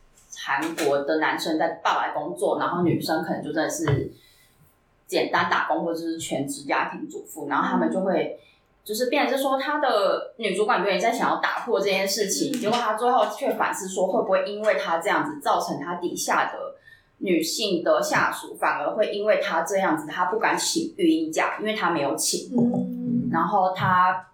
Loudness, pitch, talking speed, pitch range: -24 LUFS, 195 Hz, 280 characters per minute, 165-265 Hz